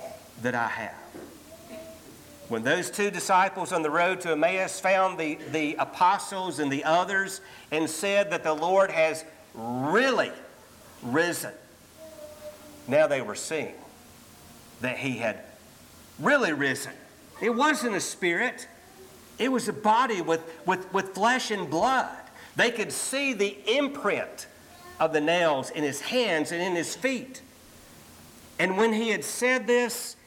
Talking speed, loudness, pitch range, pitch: 140 wpm, -26 LUFS, 165-240 Hz, 190 Hz